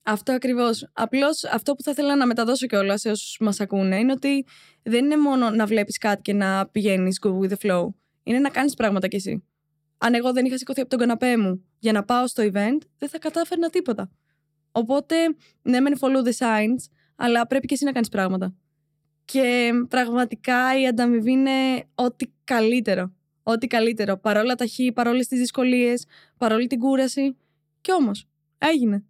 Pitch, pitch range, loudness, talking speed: 240 Hz, 205-260 Hz, -22 LUFS, 180 wpm